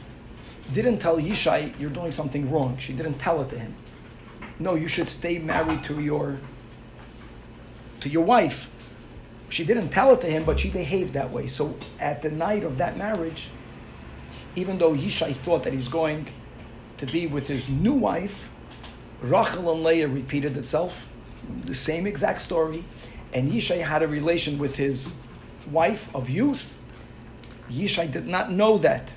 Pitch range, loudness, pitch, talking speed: 135-170 Hz, -25 LUFS, 155 Hz, 160 wpm